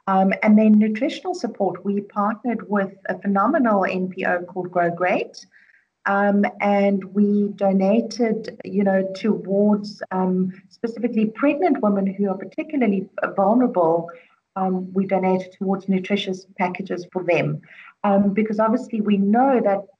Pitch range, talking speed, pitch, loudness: 190-215 Hz, 130 wpm, 200 Hz, -21 LUFS